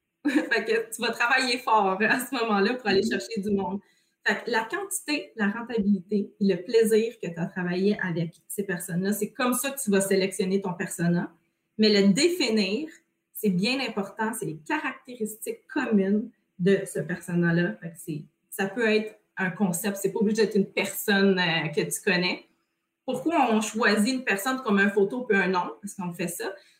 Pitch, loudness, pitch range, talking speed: 205 Hz, -26 LUFS, 190-230 Hz, 190 wpm